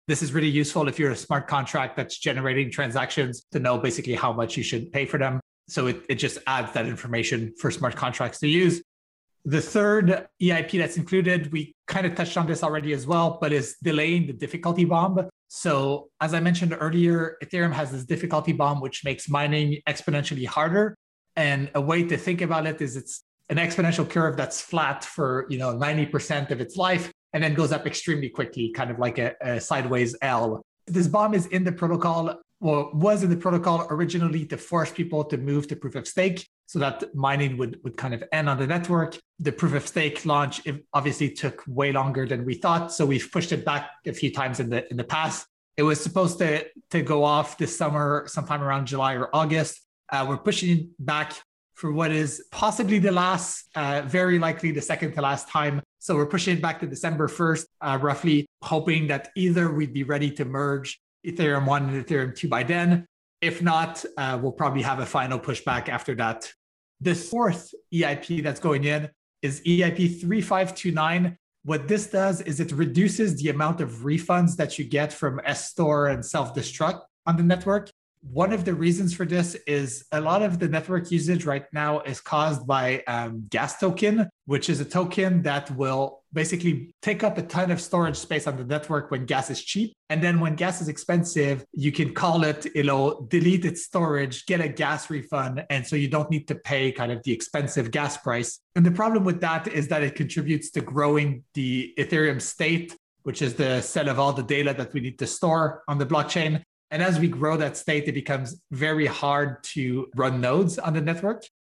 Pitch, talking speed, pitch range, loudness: 155 Hz, 205 wpm, 140-170 Hz, -25 LUFS